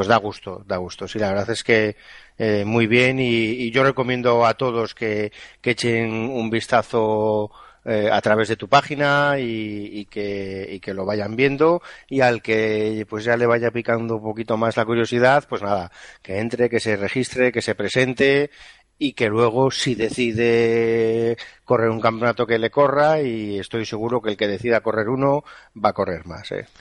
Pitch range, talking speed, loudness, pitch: 110-125 Hz, 195 wpm, -20 LUFS, 115 Hz